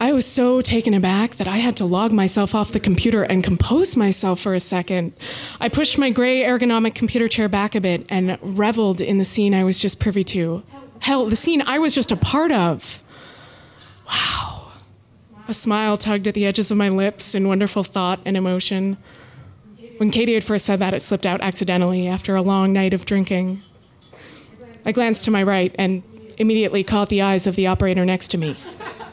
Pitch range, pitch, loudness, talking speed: 185-225 Hz, 200 Hz, -19 LUFS, 200 wpm